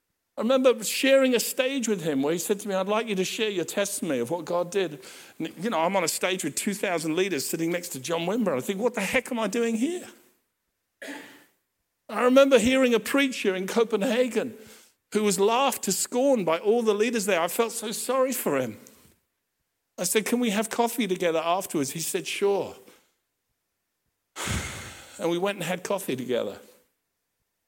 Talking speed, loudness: 190 wpm, -25 LUFS